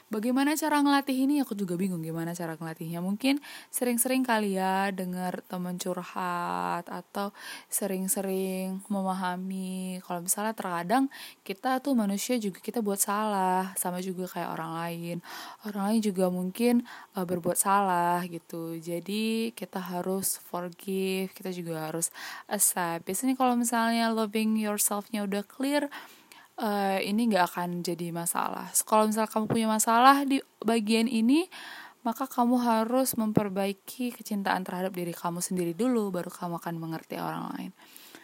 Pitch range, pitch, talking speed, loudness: 180-230 Hz, 200 Hz, 140 wpm, -29 LUFS